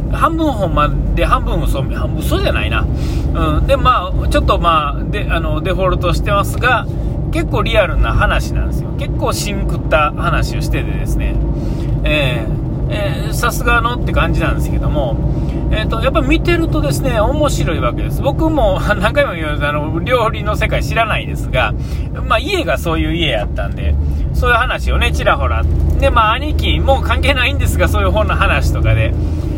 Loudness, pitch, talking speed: -15 LUFS, 80 Hz, 355 characters per minute